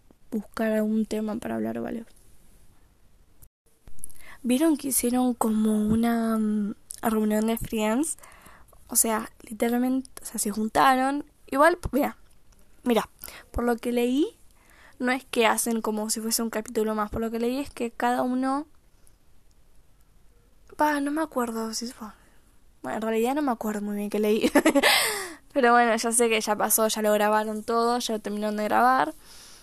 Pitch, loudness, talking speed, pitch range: 230 Hz, -25 LUFS, 160 wpm, 215-255 Hz